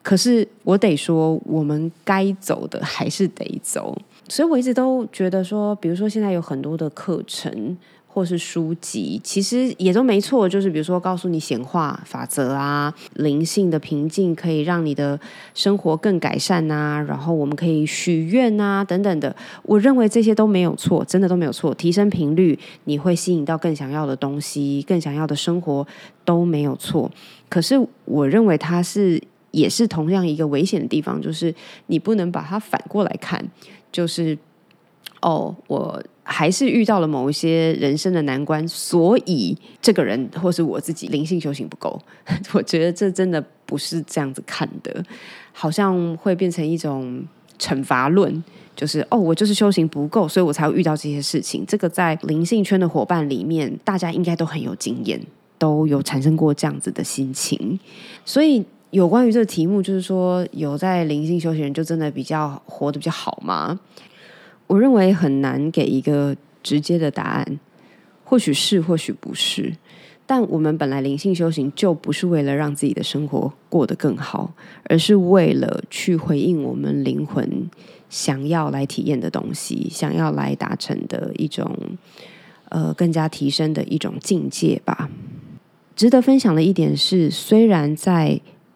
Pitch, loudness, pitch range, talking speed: 170 Hz, -20 LUFS, 150-195 Hz, 260 characters per minute